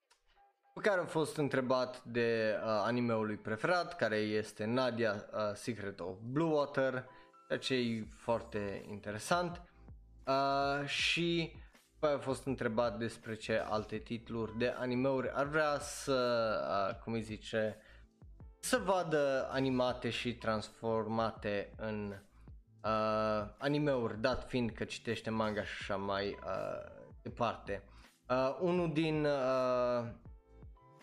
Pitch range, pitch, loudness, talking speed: 110-140 Hz, 120 Hz, -36 LUFS, 125 wpm